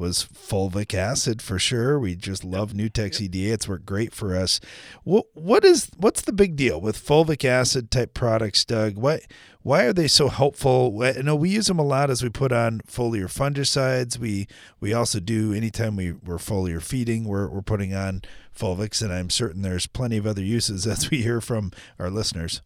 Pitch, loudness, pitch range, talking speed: 110 Hz, -23 LUFS, 100-125 Hz, 200 wpm